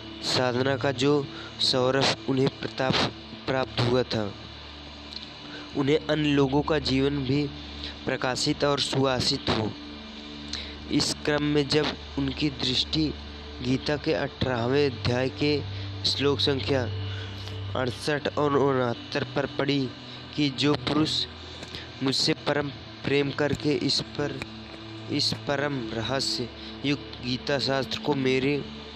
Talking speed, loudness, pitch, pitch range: 110 wpm, -26 LUFS, 130 Hz, 110-145 Hz